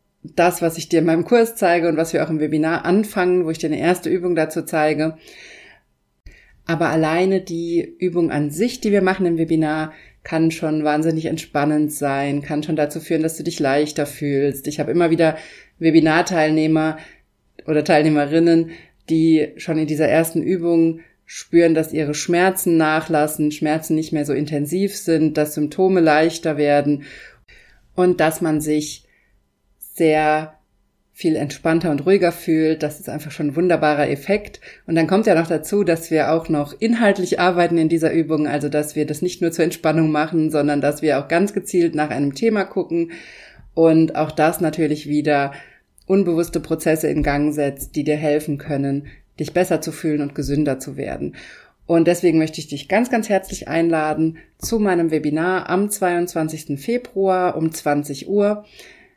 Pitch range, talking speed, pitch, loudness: 150-170 Hz, 170 wpm, 160 Hz, -19 LUFS